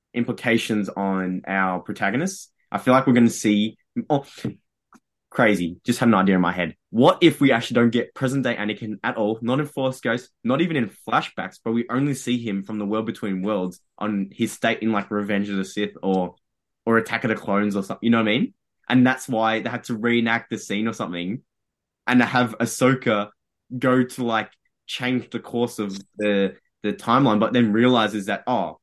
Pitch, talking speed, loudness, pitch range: 115 Hz, 210 wpm, -22 LUFS, 105-125 Hz